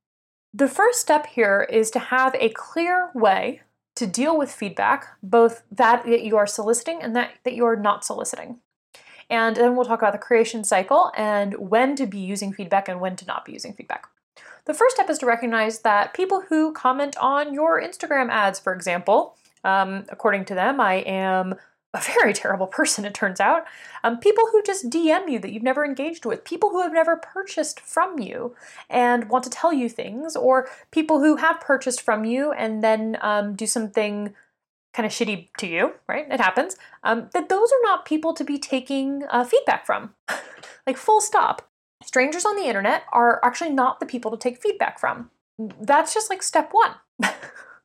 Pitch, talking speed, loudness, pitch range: 250 Hz, 190 wpm, -22 LUFS, 220-315 Hz